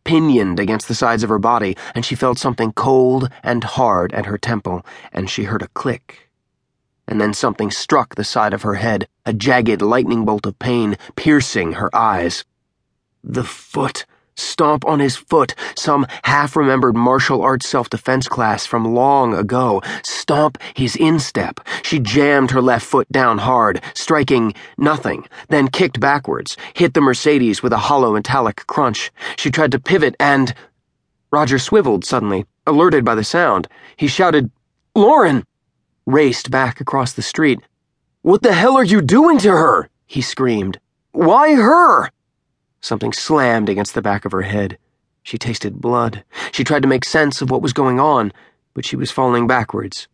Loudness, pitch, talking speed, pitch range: -16 LUFS, 125 Hz, 165 wpm, 110-140 Hz